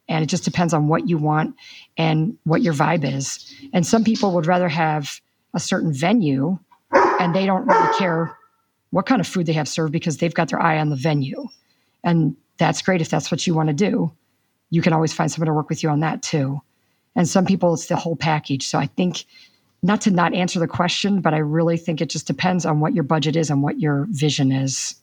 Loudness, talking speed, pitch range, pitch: -20 LUFS, 235 wpm, 155-180 Hz, 165 Hz